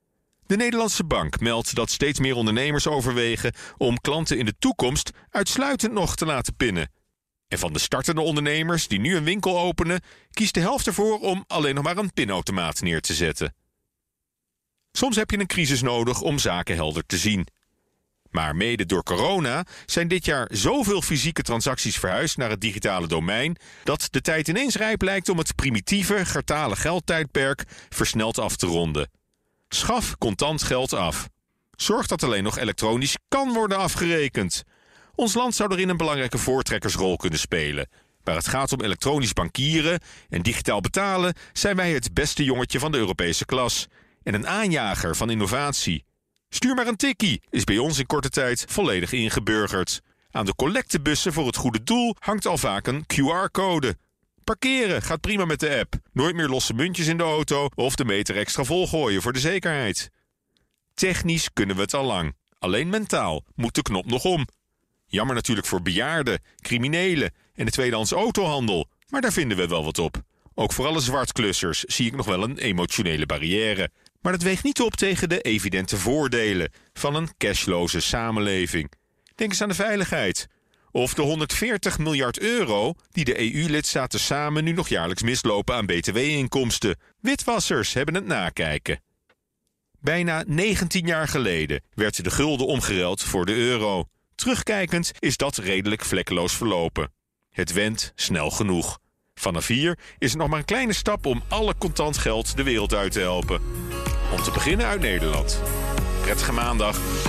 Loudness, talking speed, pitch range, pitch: -24 LUFS, 165 wpm, 105-175 Hz, 135 Hz